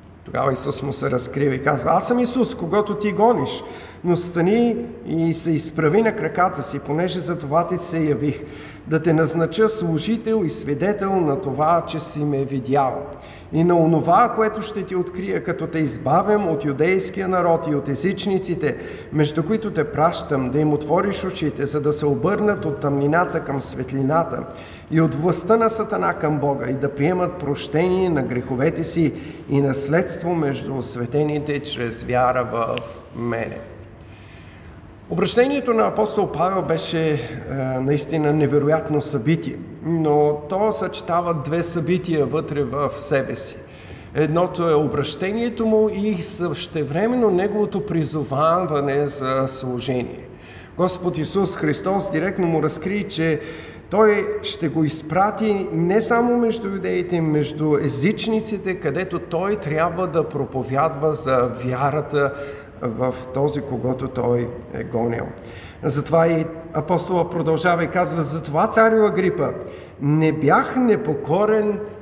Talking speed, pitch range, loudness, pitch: 135 wpm, 140-185 Hz, -21 LUFS, 160 Hz